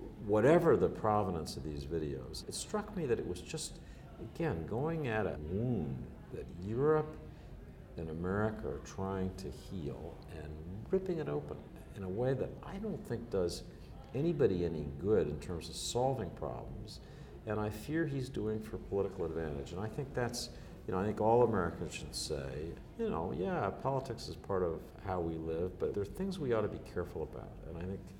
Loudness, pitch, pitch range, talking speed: -37 LUFS, 95 Hz, 80-120 Hz, 190 wpm